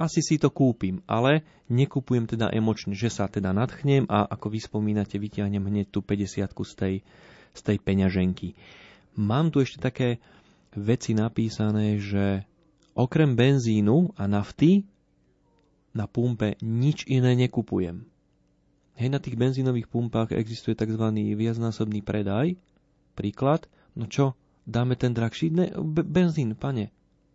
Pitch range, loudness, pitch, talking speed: 105-135 Hz, -26 LUFS, 115 Hz, 130 wpm